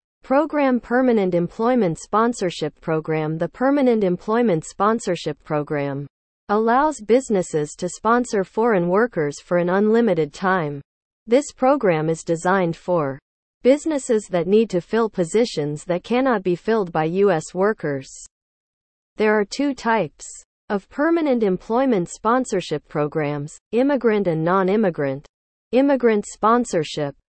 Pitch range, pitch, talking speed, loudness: 165-235 Hz, 195 Hz, 115 wpm, -20 LUFS